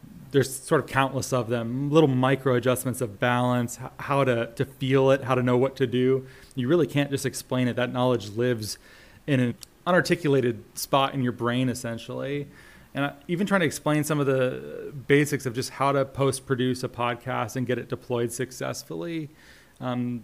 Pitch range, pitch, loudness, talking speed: 125-140 Hz, 130 Hz, -25 LUFS, 185 wpm